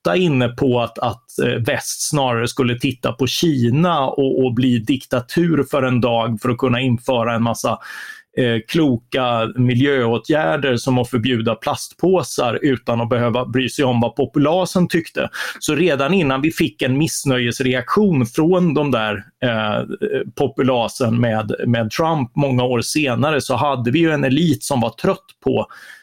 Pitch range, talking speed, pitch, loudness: 120-150 Hz, 155 wpm, 130 Hz, -18 LUFS